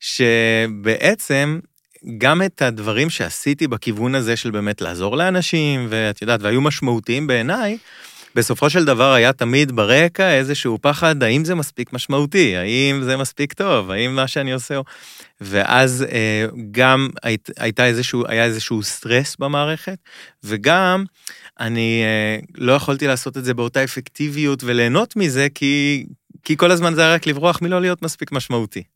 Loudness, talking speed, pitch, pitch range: -17 LUFS, 145 wpm, 130 Hz, 115-150 Hz